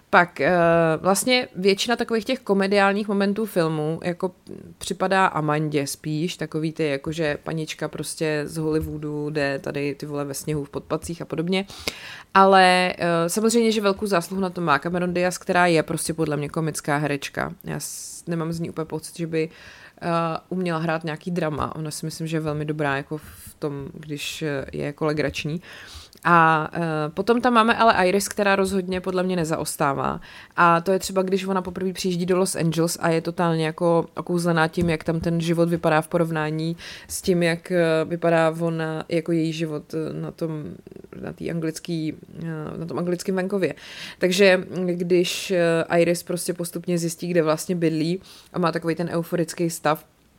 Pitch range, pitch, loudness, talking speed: 155-185 Hz, 170 Hz, -23 LUFS, 160 wpm